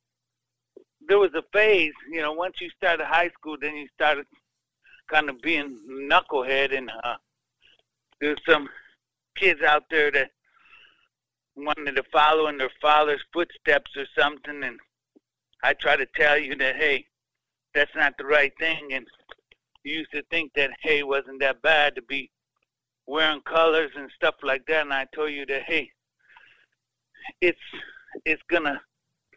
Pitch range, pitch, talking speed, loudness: 140-165 Hz, 150 Hz, 155 wpm, -23 LUFS